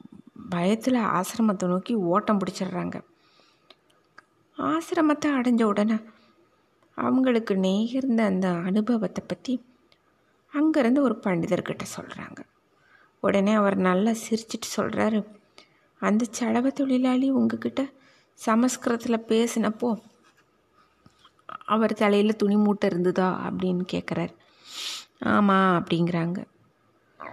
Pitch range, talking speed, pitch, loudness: 195-245 Hz, 85 wpm, 220 Hz, -25 LUFS